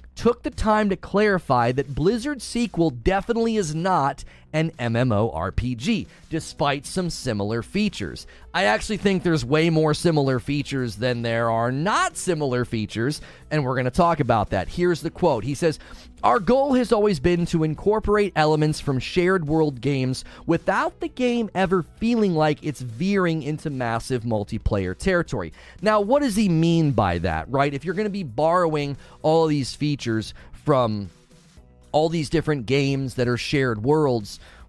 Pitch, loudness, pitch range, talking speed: 155 Hz, -23 LUFS, 125-185 Hz, 160 wpm